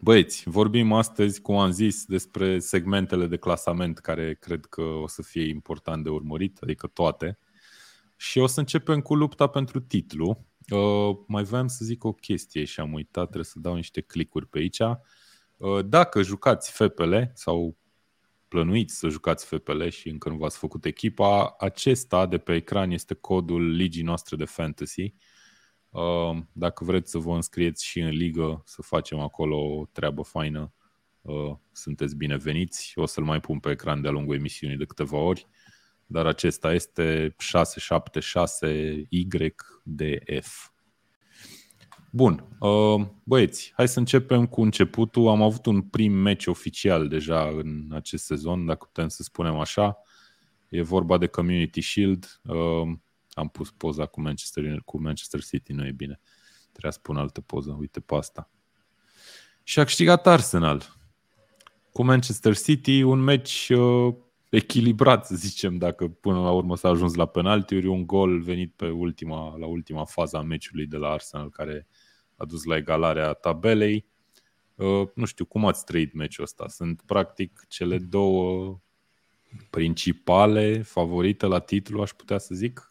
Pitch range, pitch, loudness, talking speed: 80-105 Hz, 90 Hz, -25 LUFS, 150 wpm